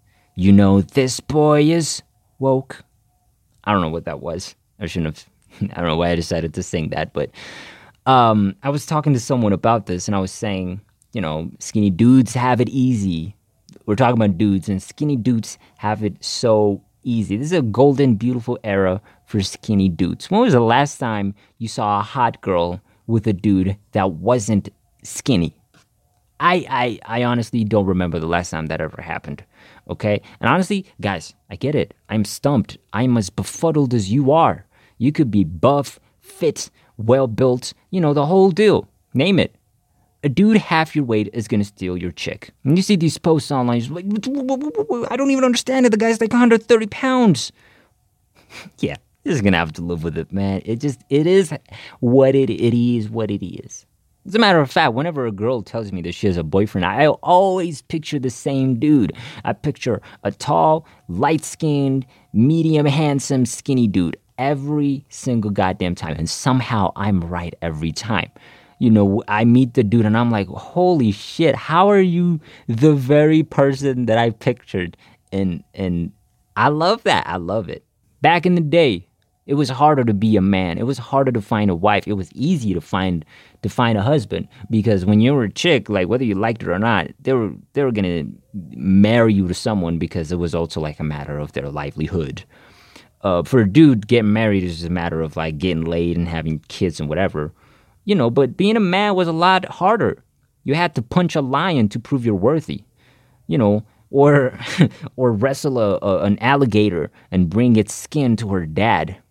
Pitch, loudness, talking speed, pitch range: 115 Hz, -18 LUFS, 195 wpm, 100-140 Hz